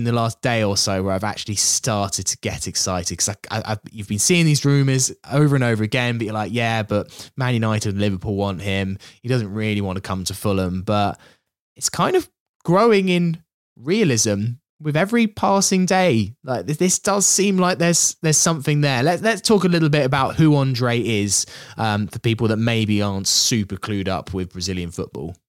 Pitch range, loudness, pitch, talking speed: 100-150 Hz, -19 LUFS, 115 Hz, 200 wpm